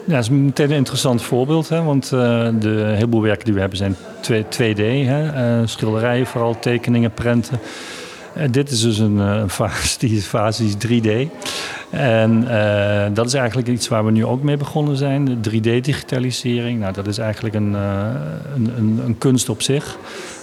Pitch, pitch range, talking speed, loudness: 115 Hz, 110-130 Hz, 190 wpm, -18 LUFS